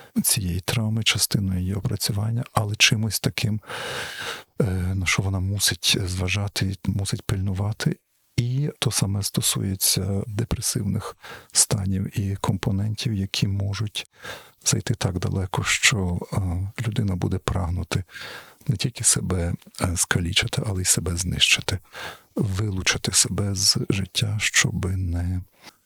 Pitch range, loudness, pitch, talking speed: 95-115 Hz, -23 LUFS, 100 Hz, 105 wpm